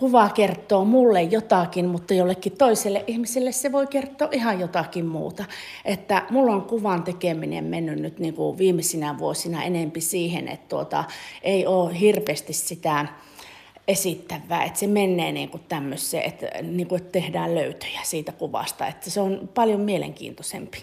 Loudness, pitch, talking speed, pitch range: -24 LUFS, 185 Hz, 145 wpm, 170-205 Hz